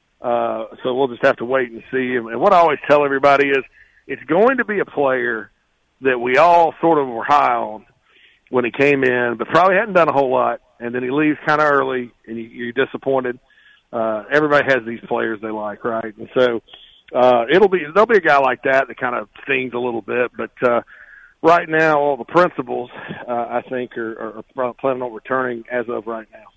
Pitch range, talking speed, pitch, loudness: 115-140 Hz, 215 wpm, 125 Hz, -18 LUFS